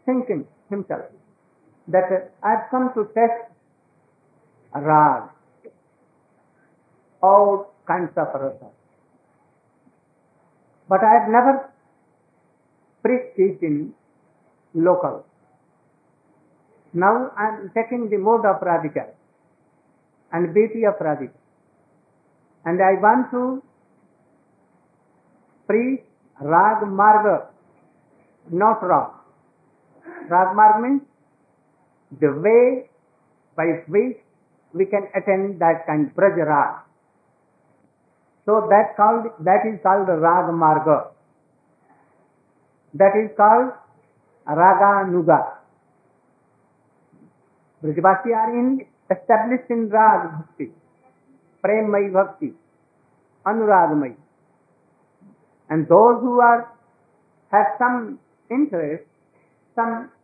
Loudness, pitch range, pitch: -19 LUFS, 170-230 Hz, 200 Hz